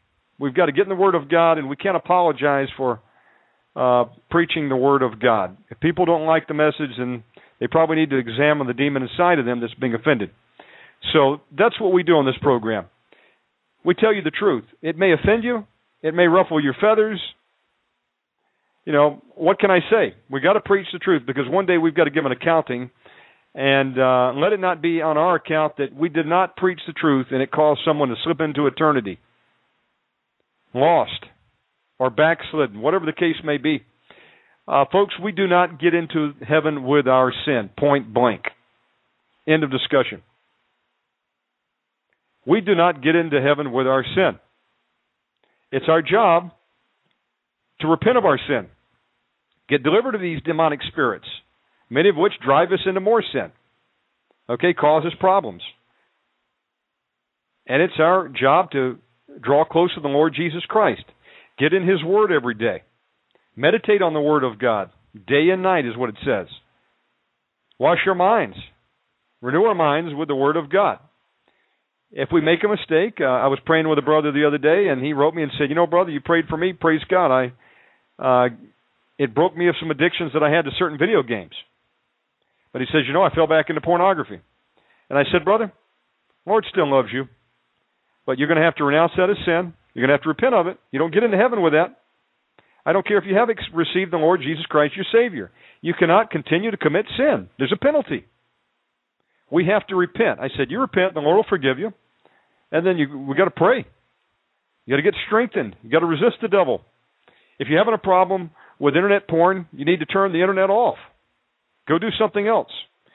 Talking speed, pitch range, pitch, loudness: 195 wpm, 140-185 Hz, 160 Hz, -19 LUFS